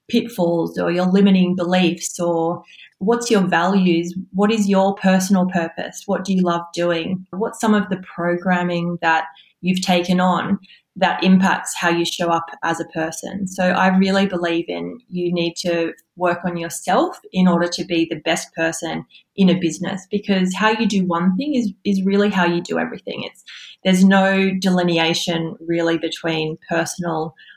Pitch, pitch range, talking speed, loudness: 180 Hz, 170-190 Hz, 170 wpm, -19 LUFS